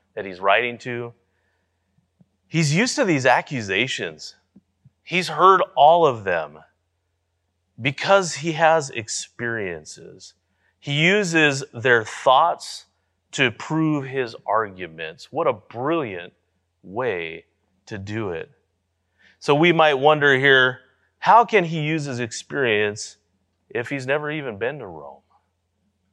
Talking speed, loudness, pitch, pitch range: 115 wpm, -20 LUFS, 125 Hz, 95-155 Hz